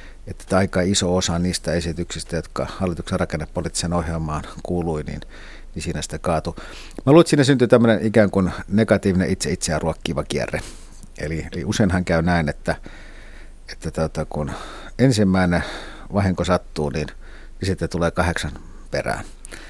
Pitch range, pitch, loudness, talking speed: 80-95 Hz, 85 Hz, -21 LUFS, 140 wpm